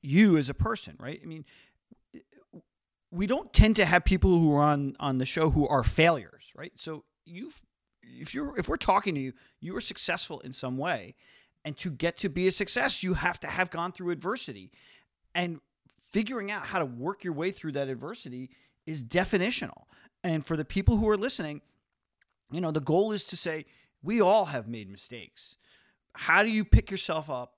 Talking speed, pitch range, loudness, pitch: 195 wpm, 145-195 Hz, -28 LUFS, 170 Hz